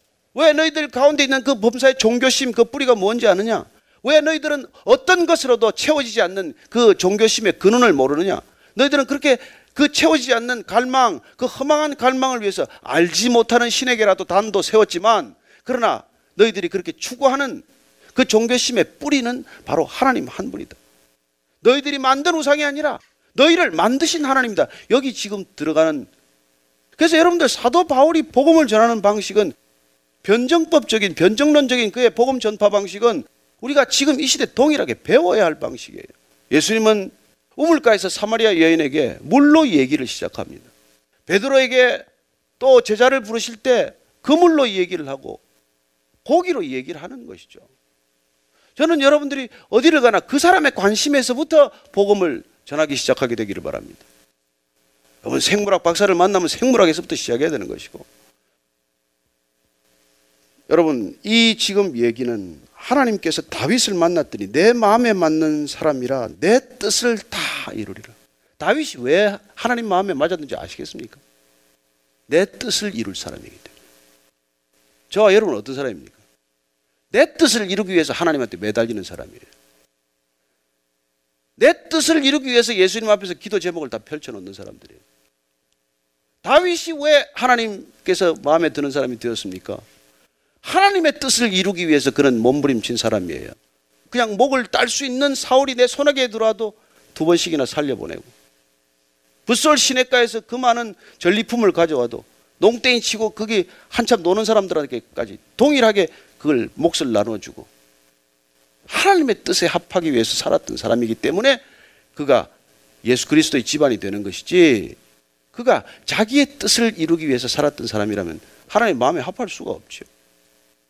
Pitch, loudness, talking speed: 210 Hz, -17 LUFS, 335 characters per minute